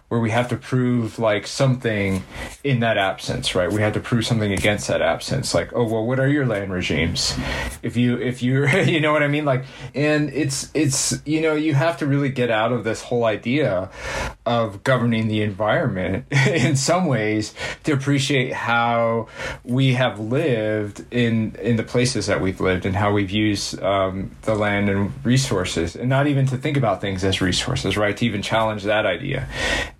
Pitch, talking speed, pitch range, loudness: 115 Hz, 190 wpm, 105-135 Hz, -21 LUFS